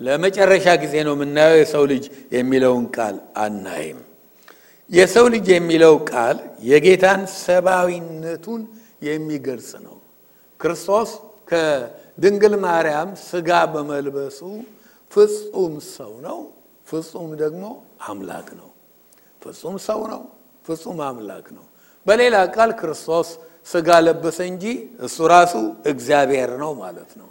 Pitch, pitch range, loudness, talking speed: 165 Hz, 150-195 Hz, -18 LUFS, 105 wpm